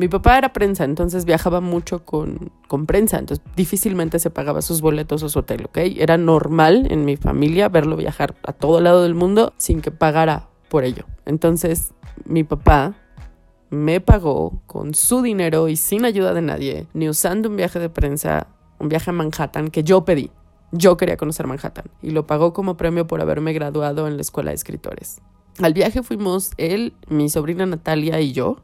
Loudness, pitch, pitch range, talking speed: -18 LUFS, 160 Hz, 150-180 Hz, 185 wpm